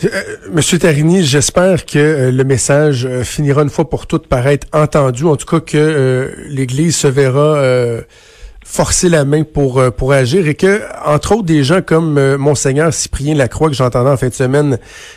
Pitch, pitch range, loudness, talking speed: 145 Hz, 135-160 Hz, -12 LUFS, 190 wpm